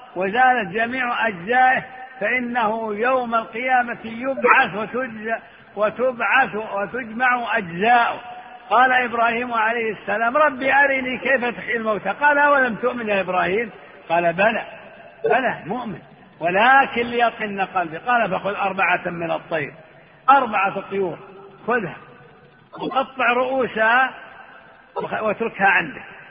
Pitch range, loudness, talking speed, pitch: 205-255 Hz, -20 LUFS, 105 wpm, 230 Hz